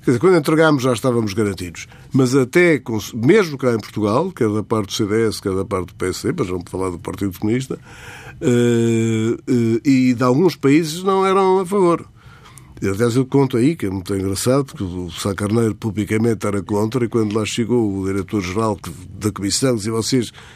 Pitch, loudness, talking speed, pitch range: 115 Hz, -18 LUFS, 175 wpm, 105-130 Hz